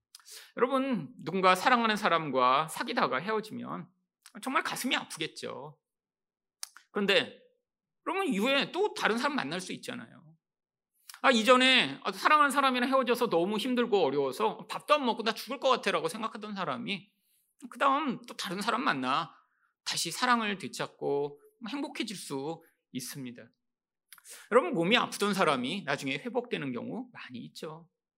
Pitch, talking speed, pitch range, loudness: 220 Hz, 315 characters per minute, 170-255 Hz, -29 LUFS